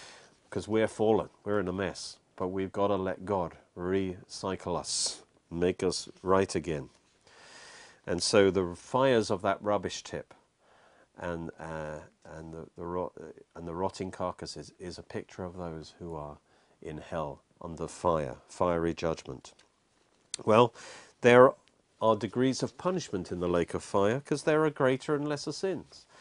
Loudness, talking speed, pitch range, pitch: -30 LUFS, 155 wpm, 85-110 Hz, 95 Hz